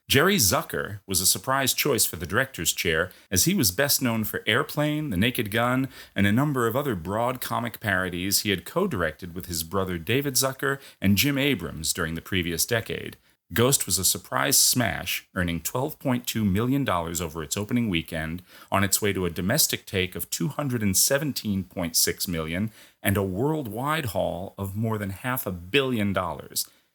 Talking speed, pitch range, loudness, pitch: 170 wpm, 90-125 Hz, -25 LUFS, 100 Hz